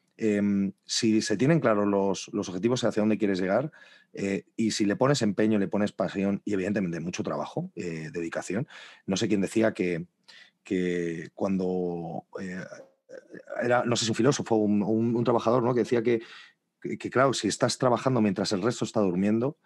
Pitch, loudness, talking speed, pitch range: 105 Hz, -27 LUFS, 185 wpm, 95-115 Hz